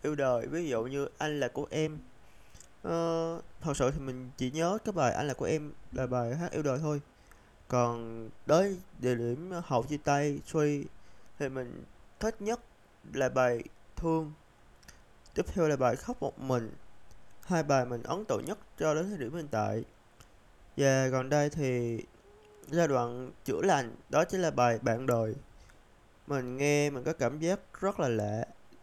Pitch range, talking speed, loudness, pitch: 120-155 Hz, 175 wpm, -32 LUFS, 140 Hz